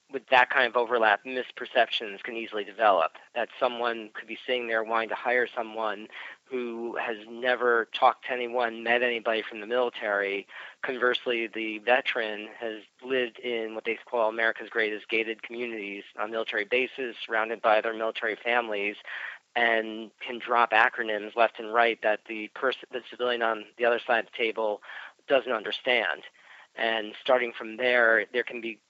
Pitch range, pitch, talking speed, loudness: 110-125 Hz, 115 Hz, 165 wpm, -27 LUFS